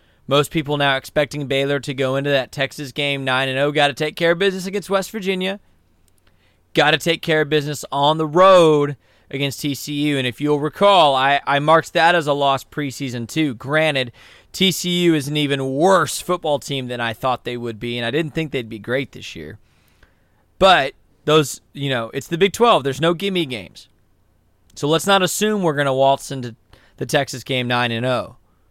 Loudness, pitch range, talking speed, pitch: -18 LUFS, 125-155 Hz, 190 wpm, 140 Hz